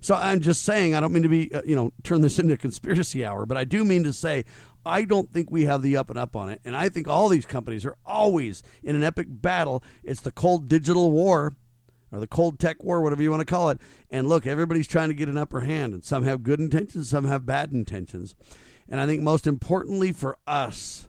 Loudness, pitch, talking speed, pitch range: -24 LUFS, 150 Hz, 250 wpm, 130-170 Hz